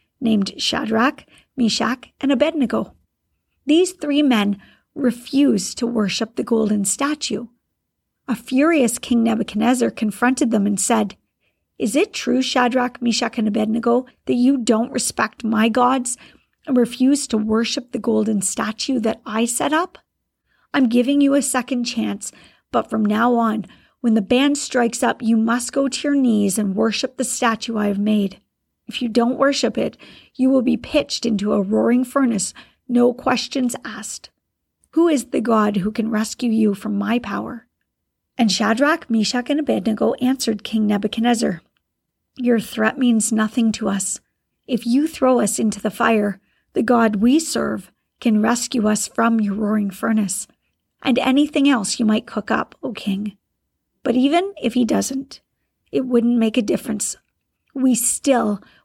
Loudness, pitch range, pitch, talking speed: -19 LUFS, 220-260 Hz, 235 Hz, 155 wpm